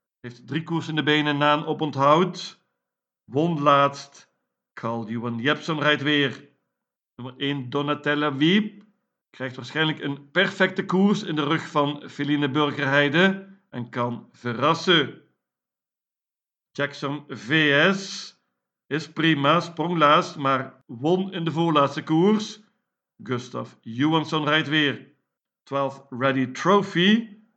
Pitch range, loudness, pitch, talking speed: 135-165 Hz, -23 LUFS, 150 Hz, 115 wpm